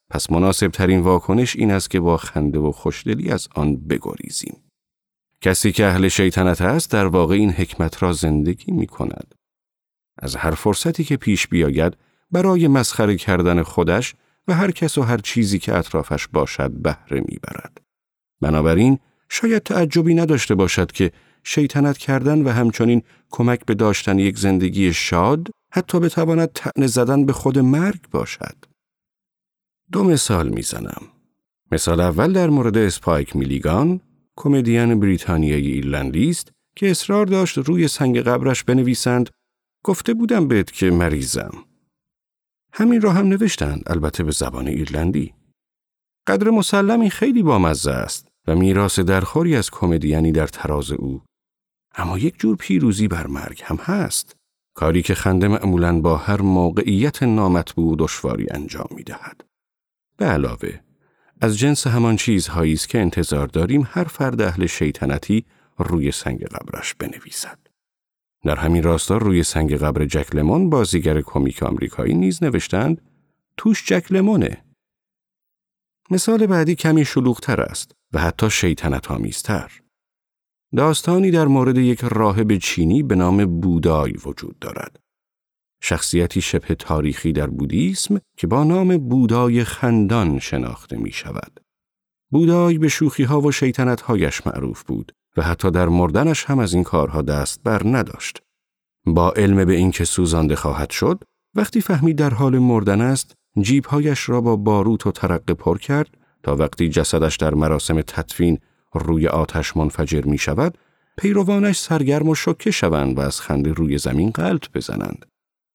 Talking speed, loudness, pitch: 140 wpm, -19 LUFS, 100 Hz